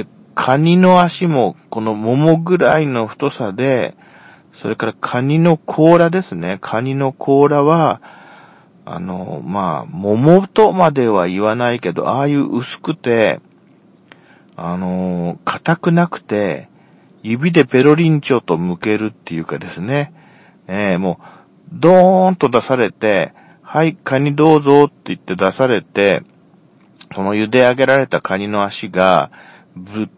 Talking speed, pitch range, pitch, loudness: 245 characters per minute, 110-160 Hz, 135 Hz, -15 LUFS